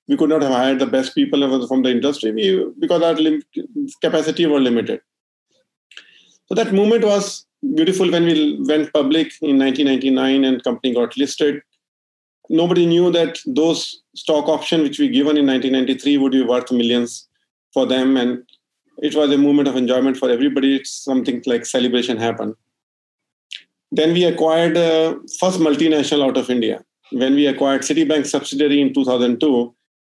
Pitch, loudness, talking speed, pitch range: 145 Hz, -17 LUFS, 160 wpm, 130-160 Hz